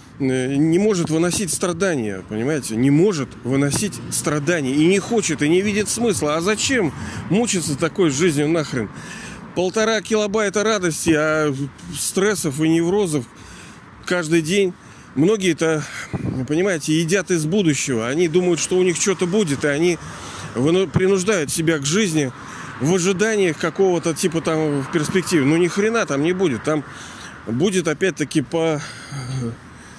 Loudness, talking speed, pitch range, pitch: -19 LUFS, 135 wpm, 150-190 Hz, 165 Hz